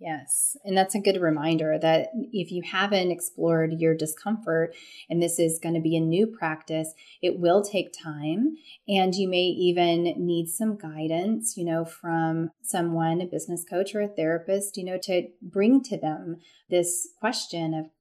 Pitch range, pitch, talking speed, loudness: 165-195 Hz, 175 Hz, 175 wpm, -26 LUFS